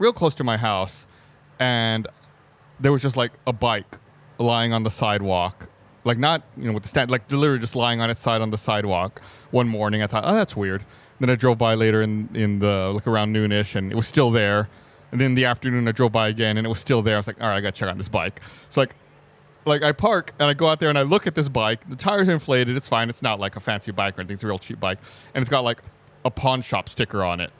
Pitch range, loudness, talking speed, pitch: 105-135 Hz, -22 LUFS, 275 wpm, 115 Hz